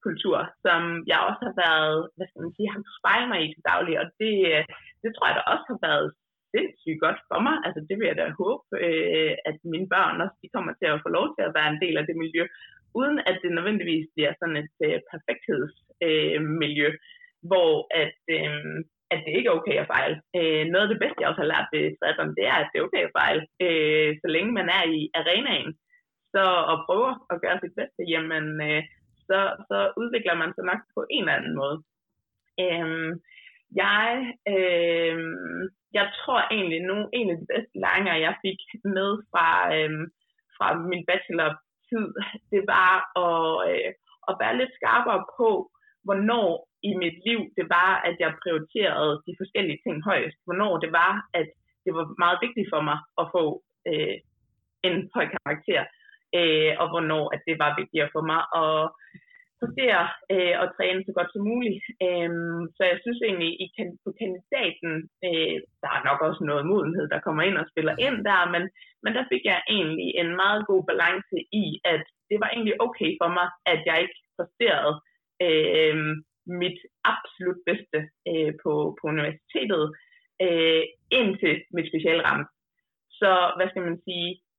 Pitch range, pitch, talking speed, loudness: 160-210 Hz, 175 Hz, 185 wpm, -25 LUFS